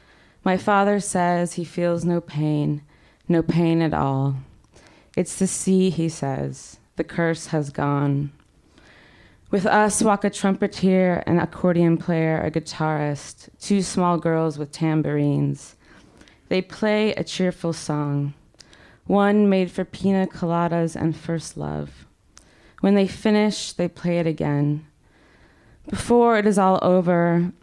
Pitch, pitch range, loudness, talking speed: 170 Hz, 150-190 Hz, -22 LUFS, 130 wpm